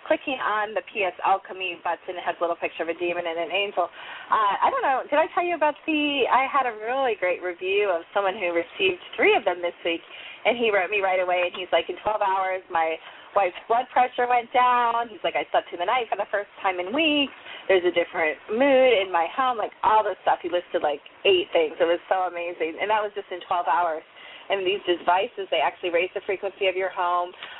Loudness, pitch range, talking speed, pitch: -24 LUFS, 175-255 Hz, 240 wpm, 195 Hz